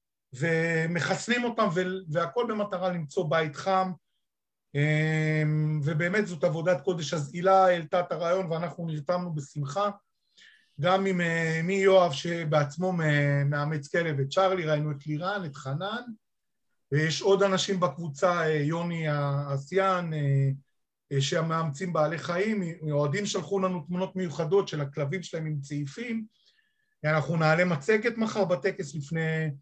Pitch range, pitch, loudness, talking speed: 150-190 Hz, 170 Hz, -28 LUFS, 120 wpm